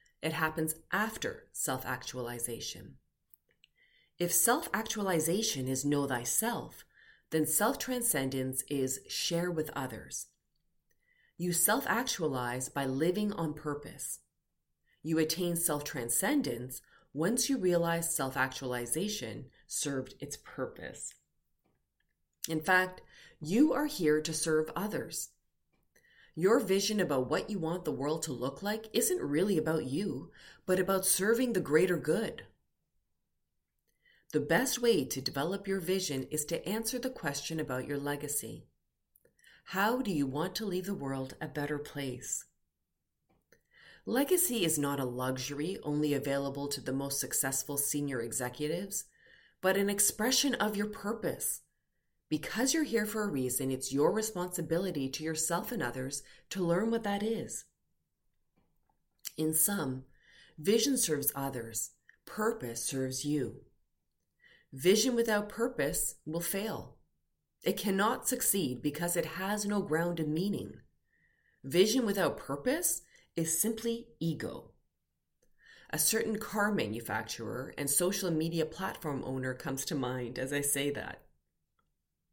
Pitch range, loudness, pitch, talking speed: 135-200 Hz, -32 LUFS, 155 Hz, 125 wpm